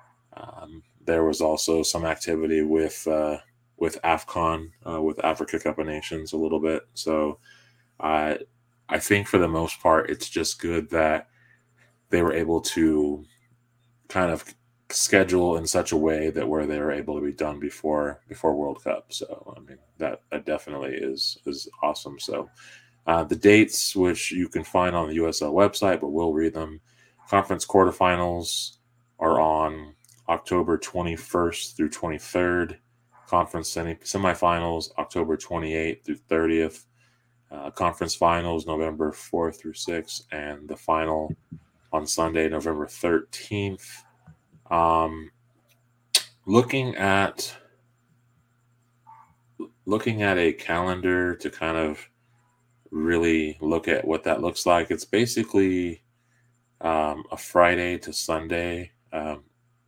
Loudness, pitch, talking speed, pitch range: -25 LUFS, 85 Hz, 135 wpm, 80-115 Hz